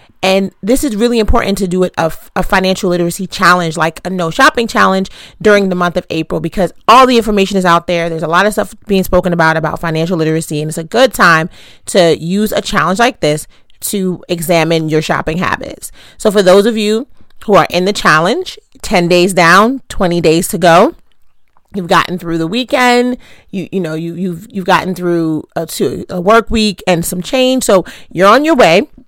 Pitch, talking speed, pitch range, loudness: 185 Hz, 205 wpm, 170-210 Hz, -11 LUFS